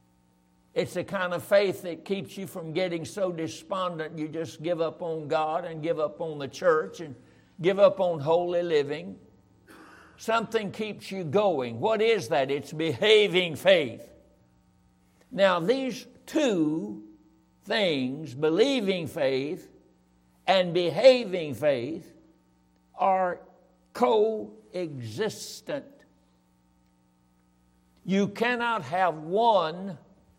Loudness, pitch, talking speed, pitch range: -27 LUFS, 175 Hz, 110 wpm, 135-195 Hz